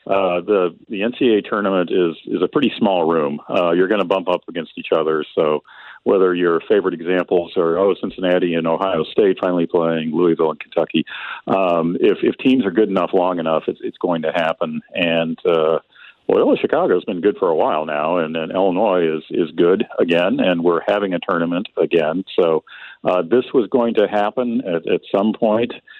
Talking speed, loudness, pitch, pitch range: 195 wpm, -18 LUFS, 90 Hz, 85-105 Hz